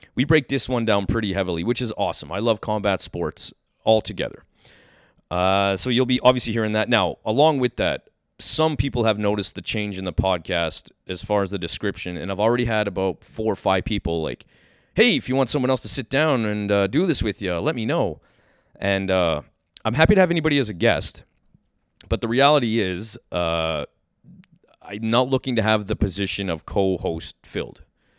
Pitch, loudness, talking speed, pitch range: 105 Hz, -22 LUFS, 200 wpm, 95-125 Hz